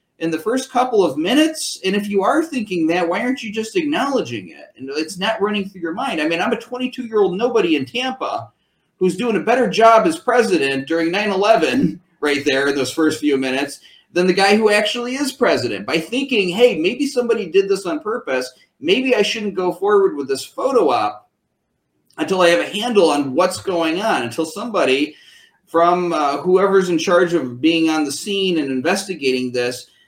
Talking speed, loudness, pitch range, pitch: 200 wpm, -18 LUFS, 160-240 Hz, 190 Hz